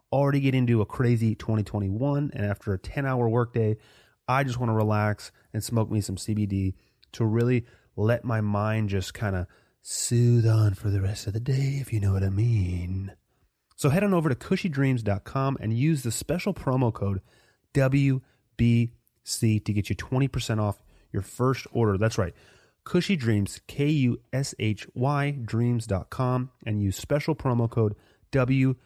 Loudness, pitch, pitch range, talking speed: -26 LUFS, 115 Hz, 105-130 Hz, 165 wpm